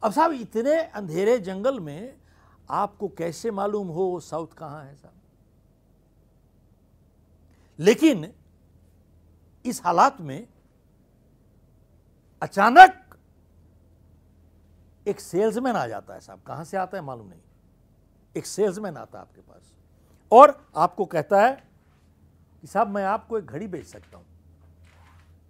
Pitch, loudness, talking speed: 135 Hz, -21 LUFS, 120 wpm